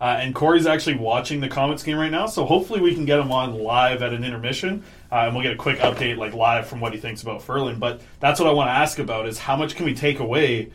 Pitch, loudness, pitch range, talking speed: 130 Hz, -21 LUFS, 115-150 Hz, 285 wpm